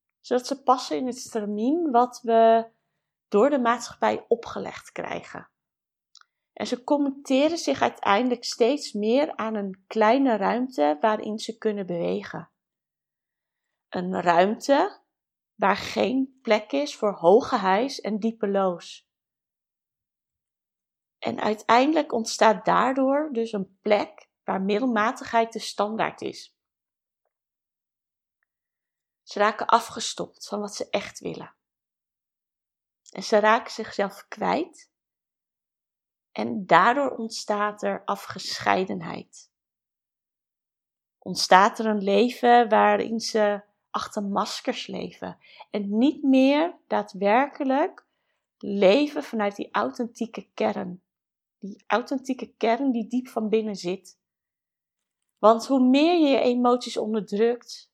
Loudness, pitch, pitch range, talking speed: -24 LUFS, 225 Hz, 205-250 Hz, 105 wpm